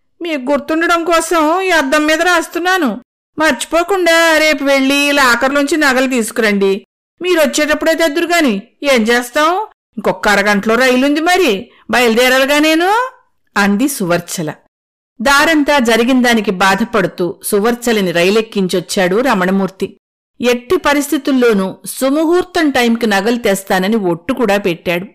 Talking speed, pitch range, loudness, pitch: 95 wpm, 210-315 Hz, -12 LUFS, 265 Hz